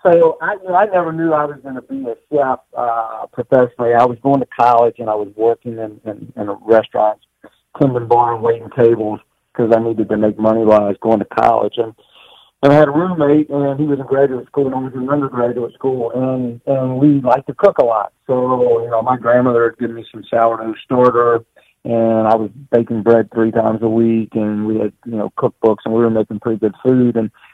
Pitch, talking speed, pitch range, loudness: 120 Hz, 230 wpm, 110-130 Hz, -15 LUFS